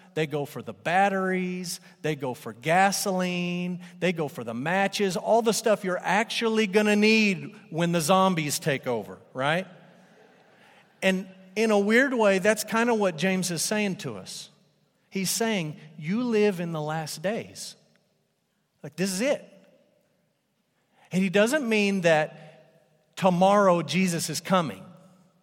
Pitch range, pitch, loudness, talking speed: 160-205 Hz, 185 Hz, -25 LUFS, 150 wpm